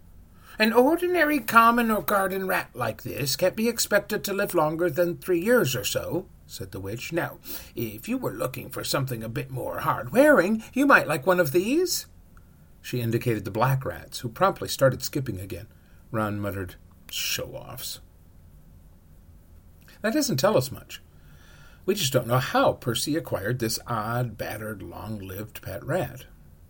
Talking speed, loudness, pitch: 165 wpm, -25 LUFS, 120 Hz